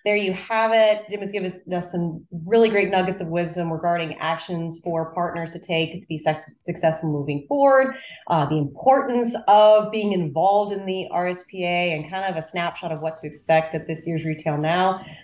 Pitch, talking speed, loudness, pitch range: 175 Hz, 195 wpm, -22 LUFS, 160-200 Hz